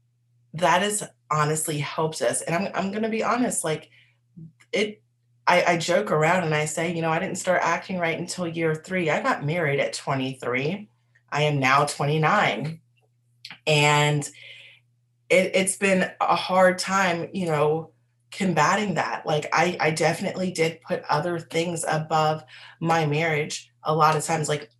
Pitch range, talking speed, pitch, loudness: 140-175 Hz, 160 wpm, 155 Hz, -23 LUFS